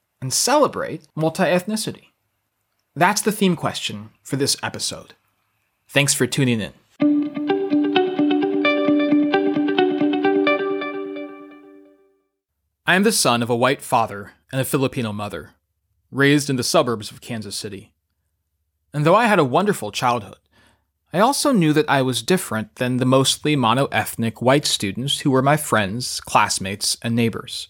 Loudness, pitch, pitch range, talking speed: -19 LUFS, 120 Hz, 100-150 Hz, 135 wpm